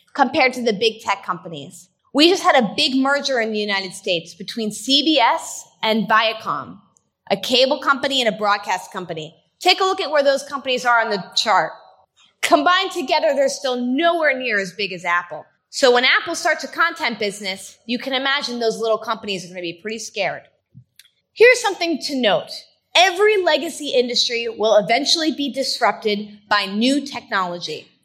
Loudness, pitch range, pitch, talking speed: -18 LUFS, 205-285 Hz, 240 Hz, 175 wpm